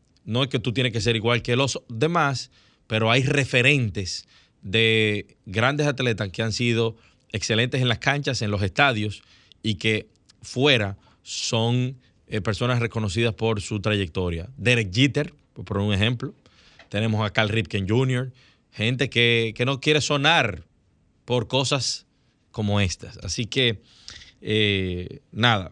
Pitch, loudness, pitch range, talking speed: 115 Hz, -23 LUFS, 105-130 Hz, 140 wpm